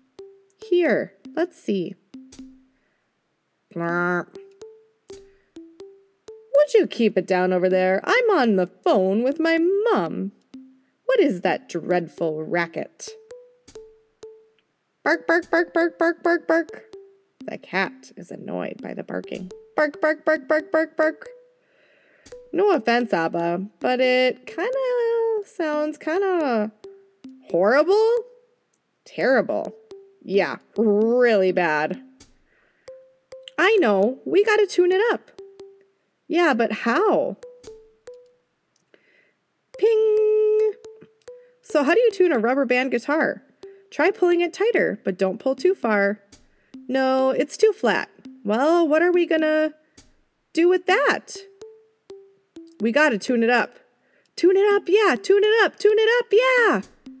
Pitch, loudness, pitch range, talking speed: 345 Hz, -21 LUFS, 260-430 Hz, 120 wpm